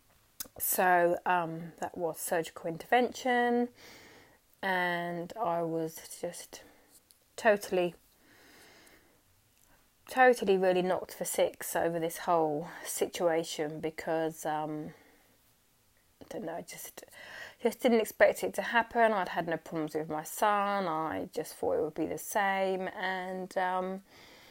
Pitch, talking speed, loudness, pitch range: 180 Hz, 120 wpm, -31 LUFS, 165-200 Hz